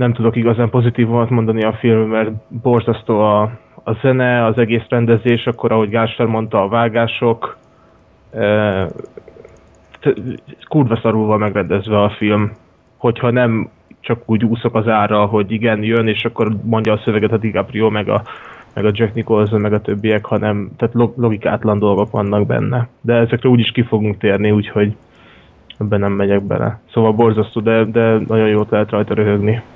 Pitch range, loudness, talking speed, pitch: 105-115 Hz, -15 LUFS, 160 wpm, 110 Hz